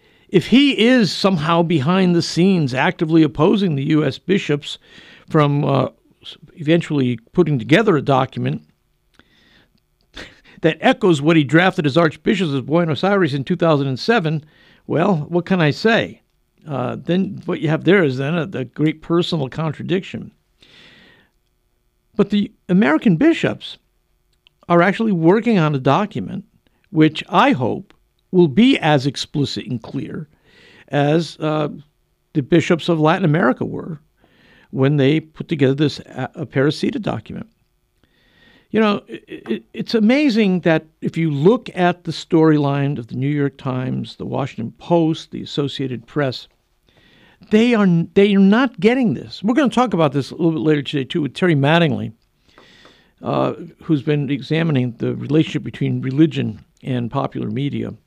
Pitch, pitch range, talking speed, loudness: 160 Hz, 140-185 Hz, 145 wpm, -18 LUFS